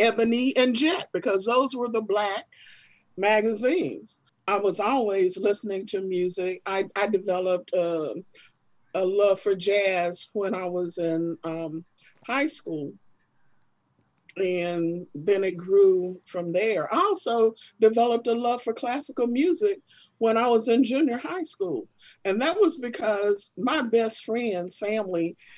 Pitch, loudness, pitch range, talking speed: 205 Hz, -25 LUFS, 185-240 Hz, 140 wpm